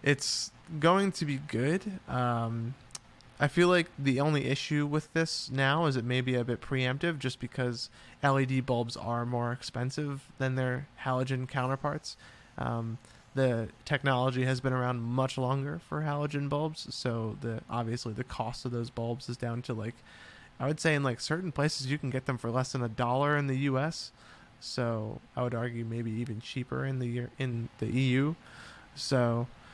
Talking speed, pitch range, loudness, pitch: 180 wpm, 120-145 Hz, -32 LUFS, 130 Hz